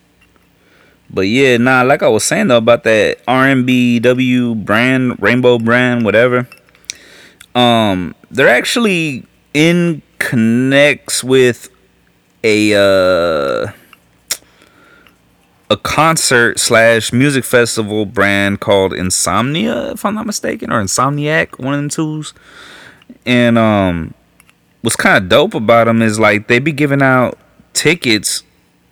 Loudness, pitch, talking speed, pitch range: -12 LUFS, 120 Hz, 115 wpm, 105-140 Hz